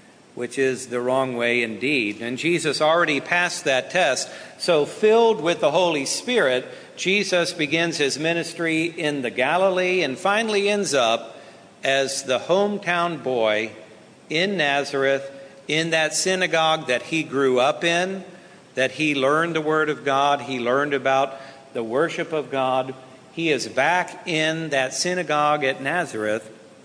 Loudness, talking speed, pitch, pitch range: -21 LUFS, 145 wpm, 150 Hz, 130-175 Hz